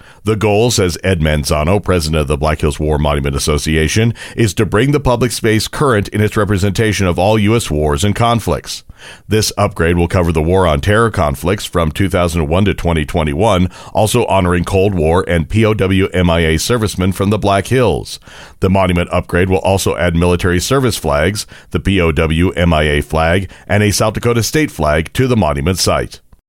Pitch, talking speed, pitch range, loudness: 95 Hz, 175 wpm, 80-105 Hz, -14 LUFS